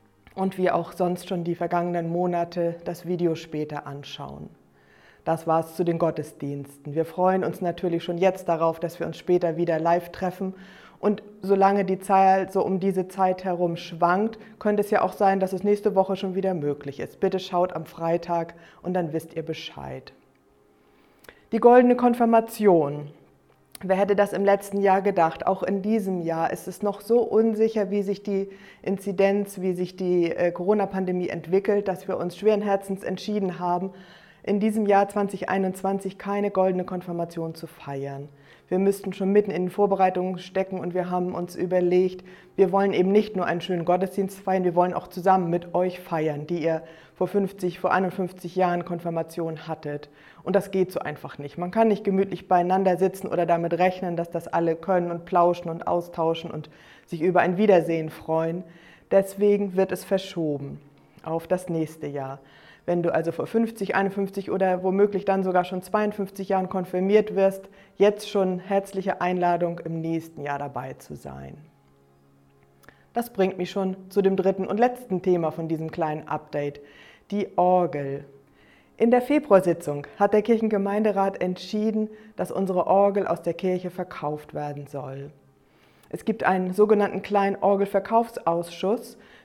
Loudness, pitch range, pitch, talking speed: -24 LUFS, 165-195 Hz, 185 Hz, 165 wpm